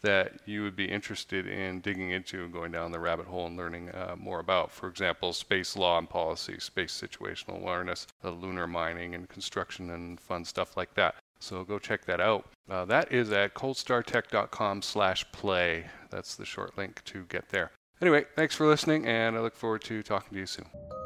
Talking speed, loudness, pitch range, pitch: 195 wpm, -31 LUFS, 85-110 Hz, 95 Hz